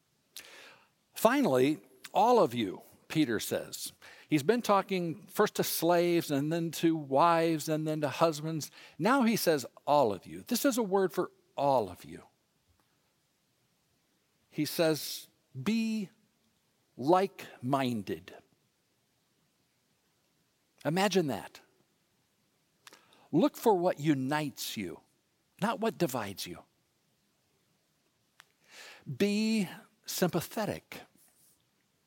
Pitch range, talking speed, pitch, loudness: 155-205 Hz, 95 wpm, 170 Hz, -30 LUFS